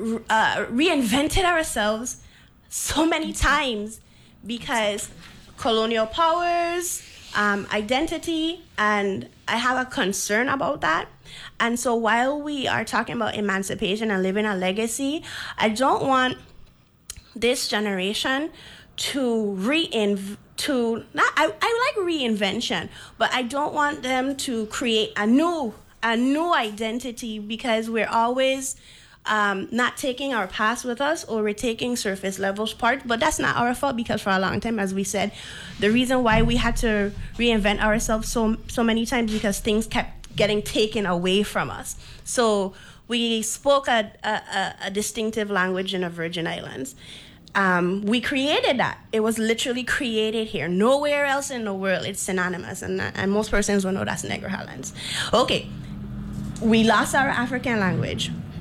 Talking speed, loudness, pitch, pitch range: 155 wpm, -23 LUFS, 225 Hz, 205-255 Hz